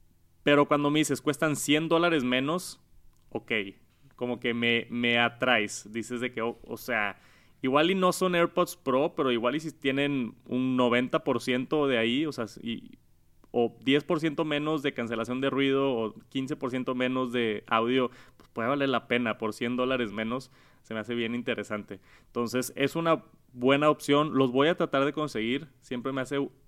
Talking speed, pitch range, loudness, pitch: 175 wpm, 120-145 Hz, -28 LUFS, 130 Hz